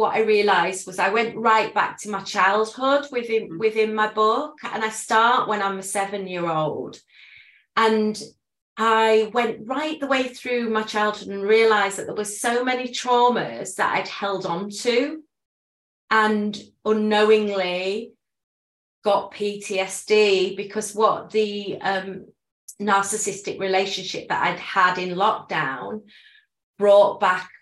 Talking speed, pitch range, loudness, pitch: 135 wpm, 195-225 Hz, -22 LUFS, 215 Hz